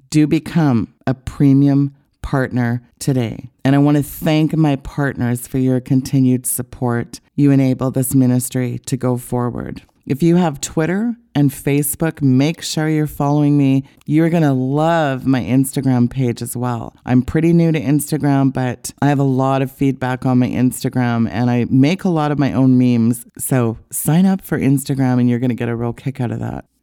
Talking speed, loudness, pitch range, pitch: 190 wpm, -17 LUFS, 125-145 Hz, 135 Hz